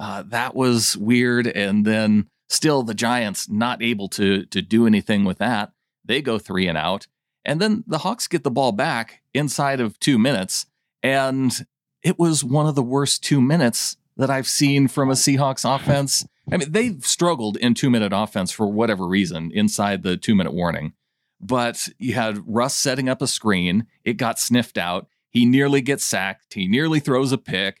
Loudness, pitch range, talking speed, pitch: -20 LUFS, 105-140 Hz, 190 wpm, 125 Hz